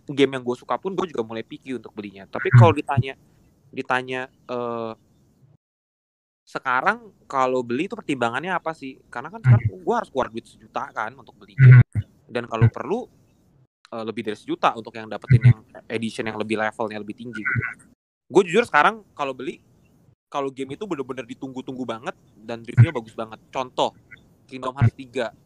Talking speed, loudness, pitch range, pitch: 170 wpm, -22 LUFS, 115-135 Hz, 125 Hz